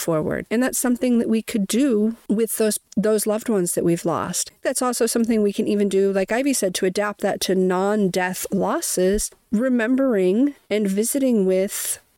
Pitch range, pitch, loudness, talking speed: 195-235 Hz, 215 Hz, -21 LUFS, 175 wpm